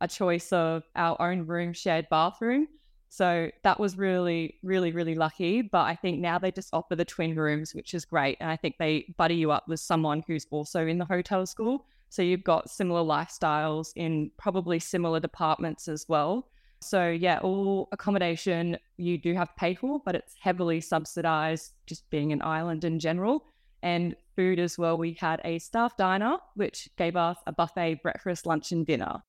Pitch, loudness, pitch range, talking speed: 170 Hz, -29 LUFS, 160-185 Hz, 190 wpm